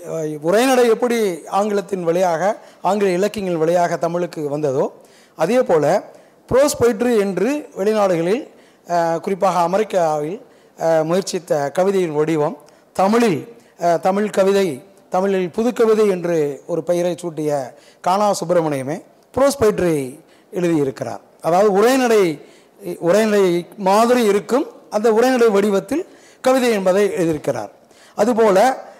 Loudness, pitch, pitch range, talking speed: -18 LUFS, 190 Hz, 170-215 Hz, 95 wpm